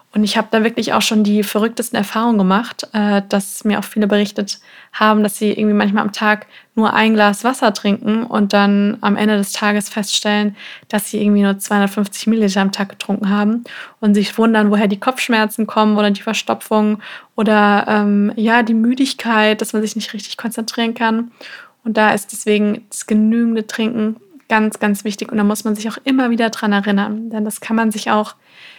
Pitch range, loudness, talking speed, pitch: 210-225 Hz, -16 LUFS, 195 wpm, 215 Hz